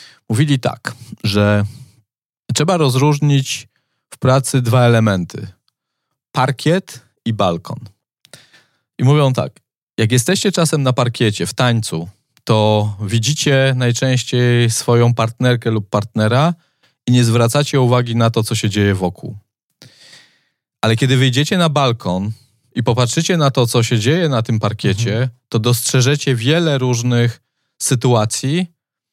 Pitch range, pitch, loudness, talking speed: 115-135 Hz, 125 Hz, -16 LUFS, 120 wpm